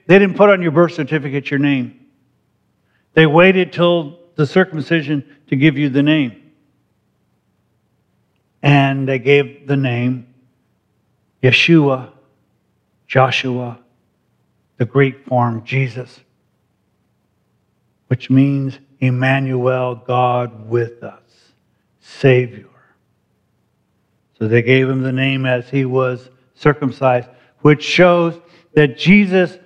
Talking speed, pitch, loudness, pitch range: 105 wpm, 135 Hz, -15 LUFS, 125-150 Hz